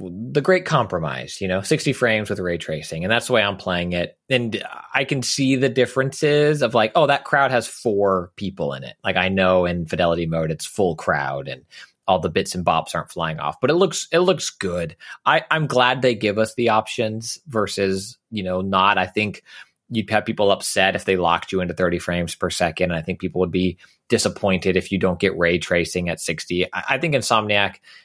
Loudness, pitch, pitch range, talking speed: -21 LUFS, 100 Hz, 90-125 Hz, 220 wpm